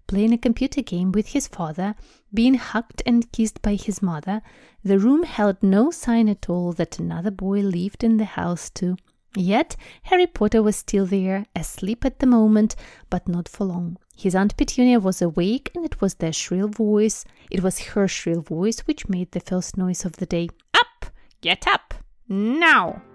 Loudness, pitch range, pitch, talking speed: -22 LUFS, 185-230 Hz, 205 Hz, 185 wpm